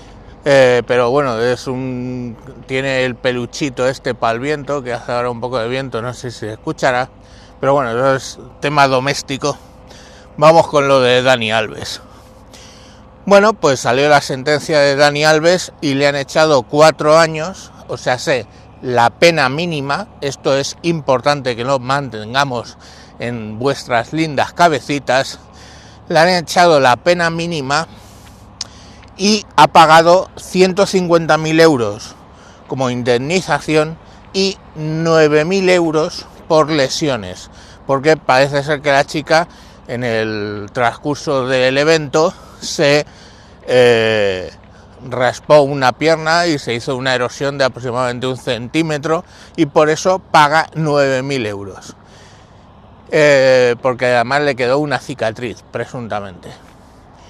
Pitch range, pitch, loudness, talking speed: 115-150 Hz, 130 Hz, -14 LUFS, 130 wpm